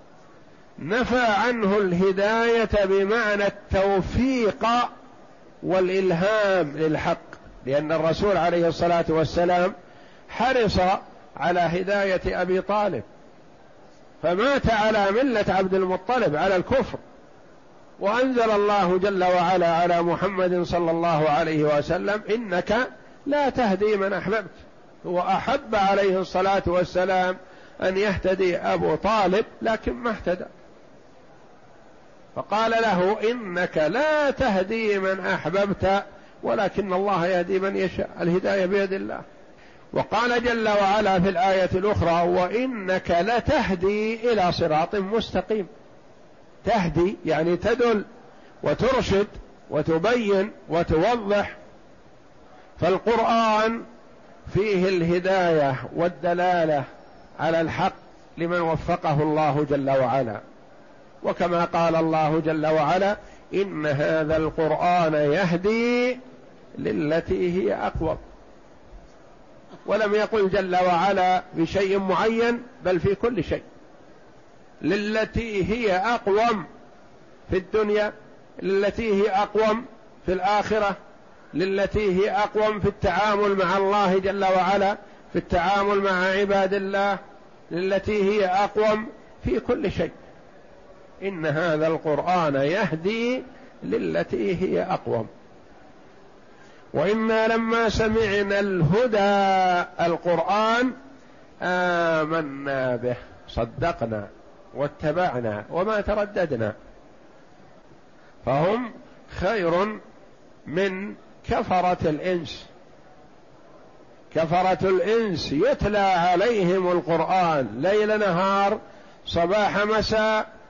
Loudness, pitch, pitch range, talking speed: -23 LUFS, 190 Hz, 175-210 Hz, 90 wpm